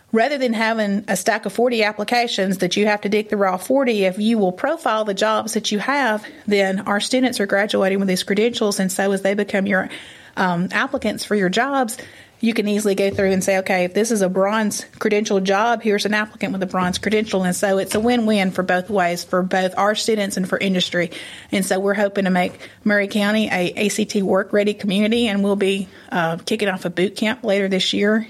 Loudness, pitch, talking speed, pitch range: -19 LUFS, 205 Hz, 225 wpm, 190-220 Hz